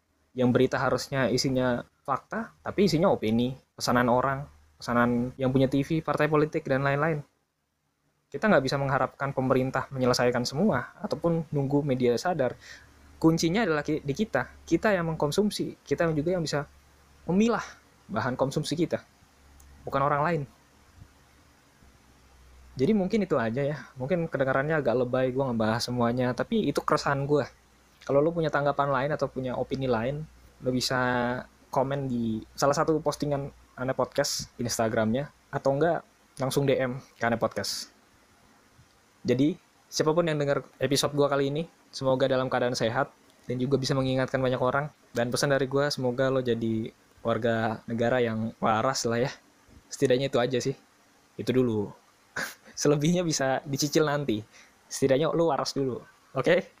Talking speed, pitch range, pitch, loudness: 145 wpm, 120-145 Hz, 130 Hz, -27 LUFS